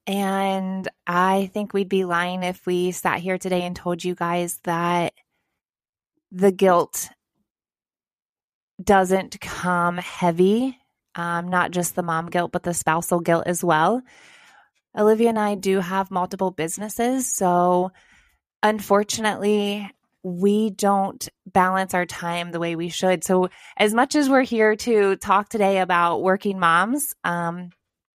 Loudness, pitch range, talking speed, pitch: -22 LUFS, 175-205 Hz, 135 wpm, 185 Hz